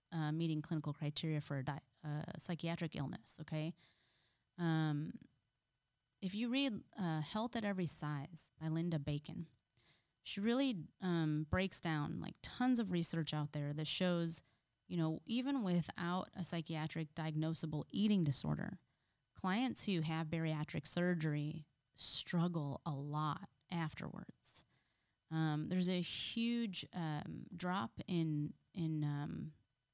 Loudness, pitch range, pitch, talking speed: -40 LUFS, 150-180 Hz, 160 Hz, 130 wpm